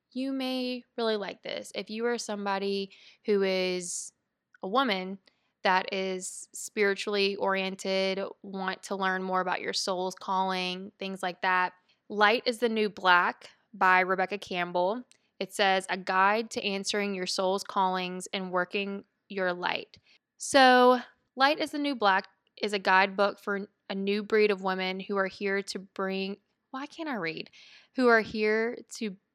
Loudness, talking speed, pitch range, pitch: -28 LUFS, 155 wpm, 190-215 Hz, 200 Hz